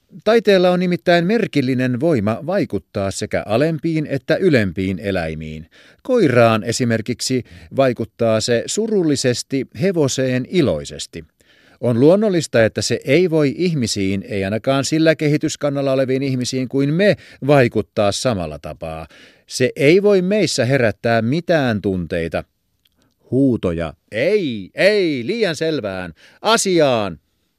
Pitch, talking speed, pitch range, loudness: 125 Hz, 105 wpm, 100-155 Hz, -17 LUFS